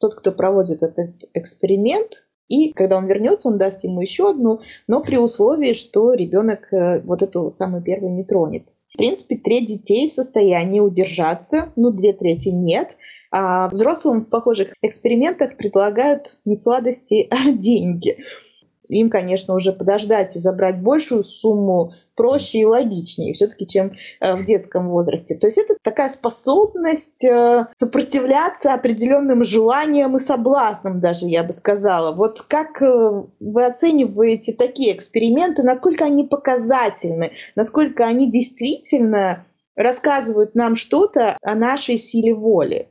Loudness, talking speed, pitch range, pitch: -17 LUFS, 135 wpm, 195-265 Hz, 225 Hz